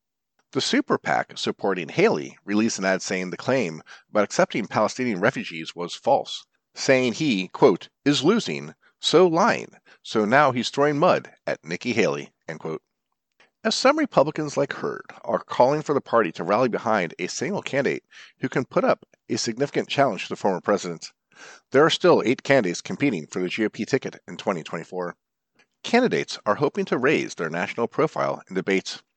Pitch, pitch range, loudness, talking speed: 110 Hz, 95-140 Hz, -23 LUFS, 170 wpm